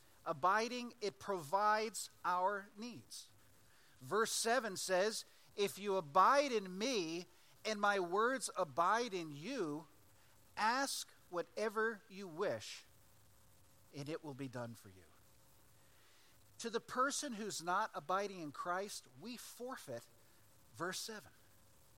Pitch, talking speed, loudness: 185 Hz, 115 wpm, -39 LUFS